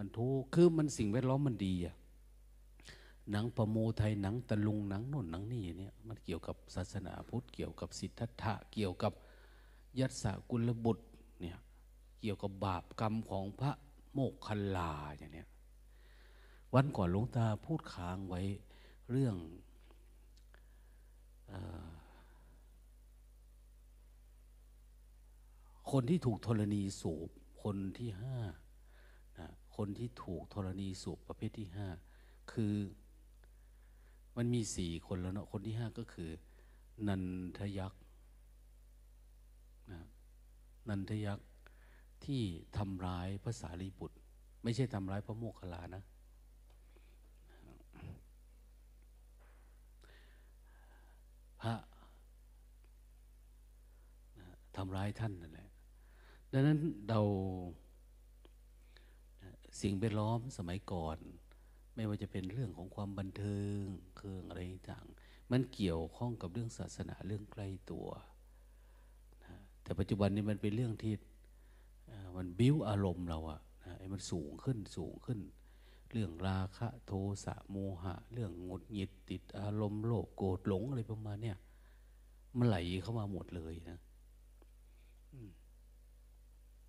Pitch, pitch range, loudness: 95 Hz, 85-110 Hz, -40 LUFS